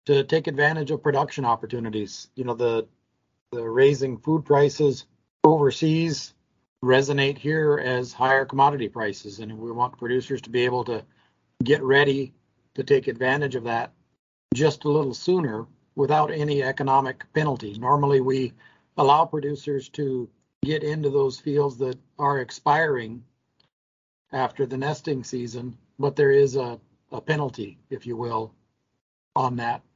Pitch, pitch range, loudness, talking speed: 135 Hz, 125-145 Hz, -24 LUFS, 140 wpm